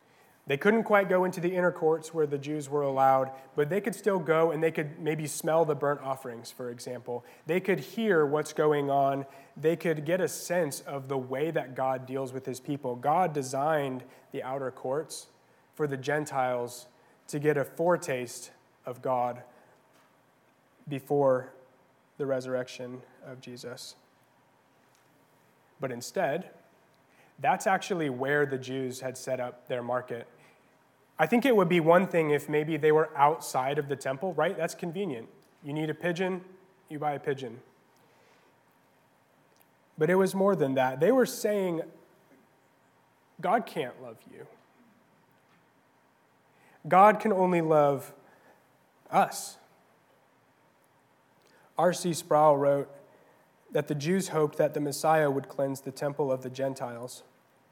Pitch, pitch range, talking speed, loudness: 145 Hz, 130-165 Hz, 145 wpm, -29 LUFS